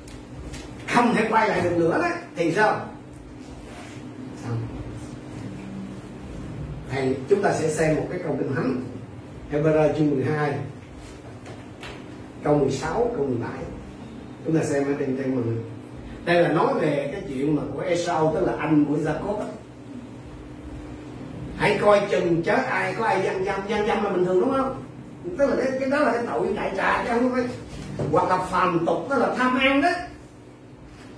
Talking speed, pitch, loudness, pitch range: 165 wpm, 150 Hz, -23 LUFS, 125-195 Hz